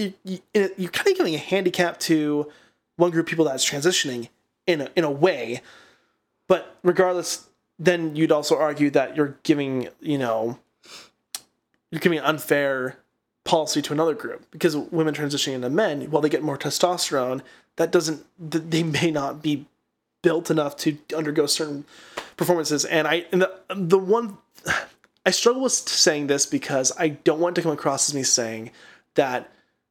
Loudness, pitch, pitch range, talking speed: -23 LUFS, 160 Hz, 145-175 Hz, 165 wpm